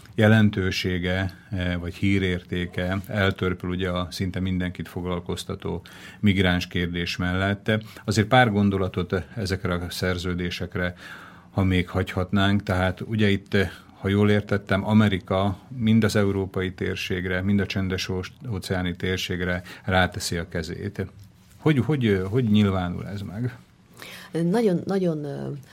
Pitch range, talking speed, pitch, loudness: 90-105 Hz, 110 wpm, 95 Hz, -25 LUFS